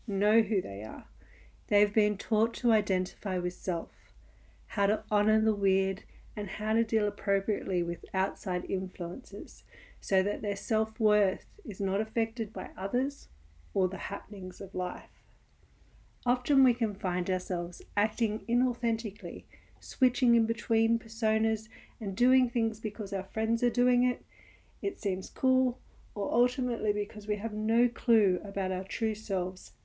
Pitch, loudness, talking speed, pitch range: 210 Hz, -30 LUFS, 145 wpm, 190-230 Hz